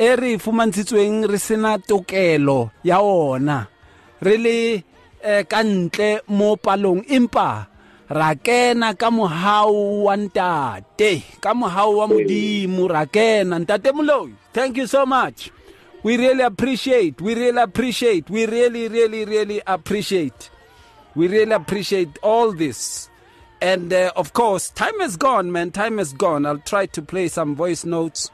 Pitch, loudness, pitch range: 205 Hz, -19 LUFS, 175-225 Hz